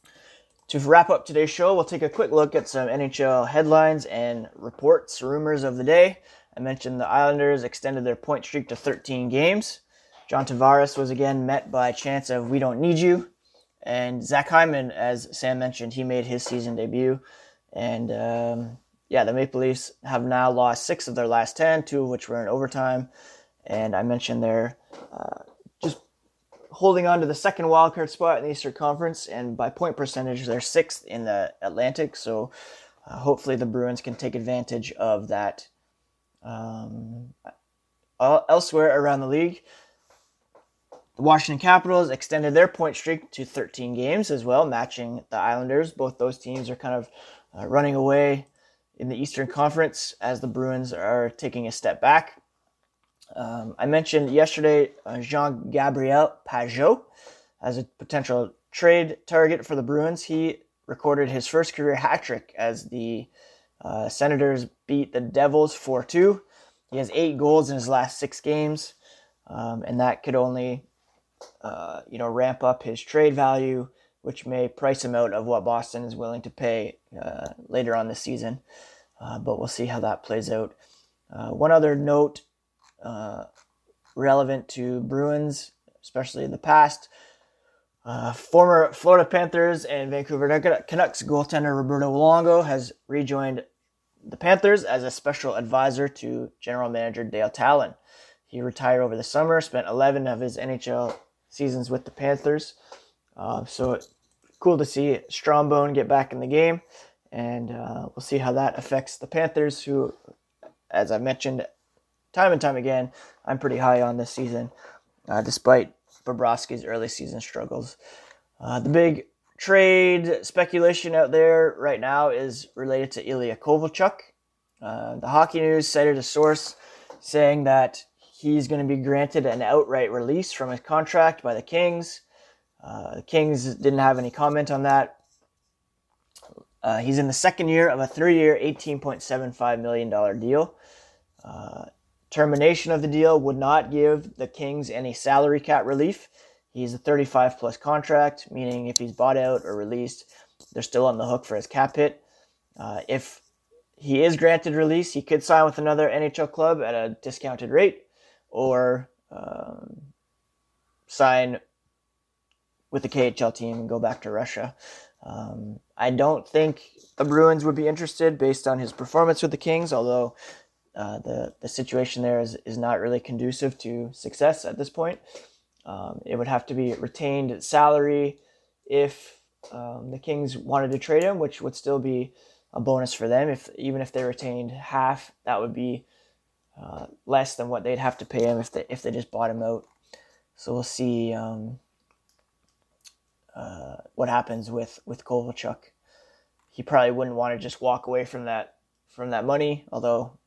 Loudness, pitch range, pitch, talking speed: -23 LUFS, 125-150 Hz, 135 Hz, 165 wpm